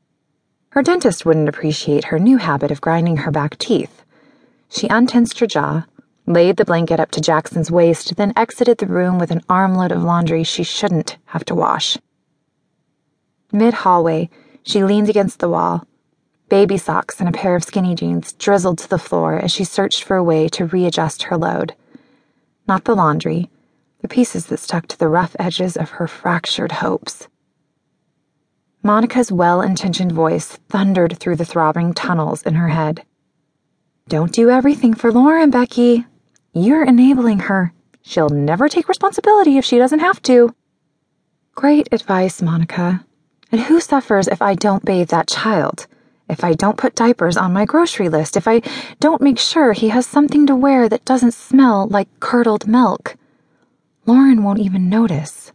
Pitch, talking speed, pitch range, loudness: 195 Hz, 165 wpm, 170-240 Hz, -15 LUFS